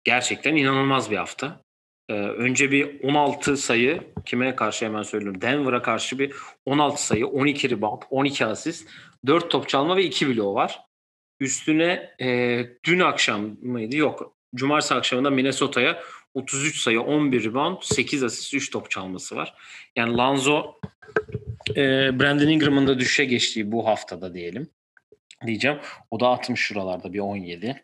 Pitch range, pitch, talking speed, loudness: 110-140 Hz, 125 Hz, 140 wpm, -23 LUFS